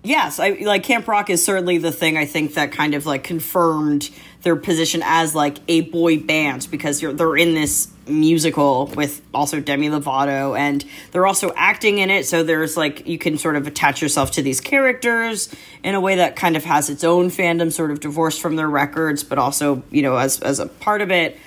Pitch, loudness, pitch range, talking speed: 160 Hz, -18 LUFS, 145-175 Hz, 215 wpm